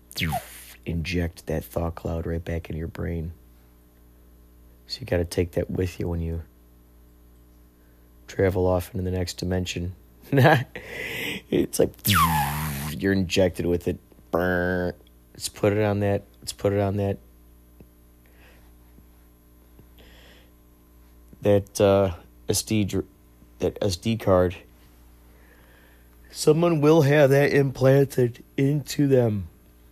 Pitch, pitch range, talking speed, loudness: 80 Hz, 60-95 Hz, 110 wpm, -24 LUFS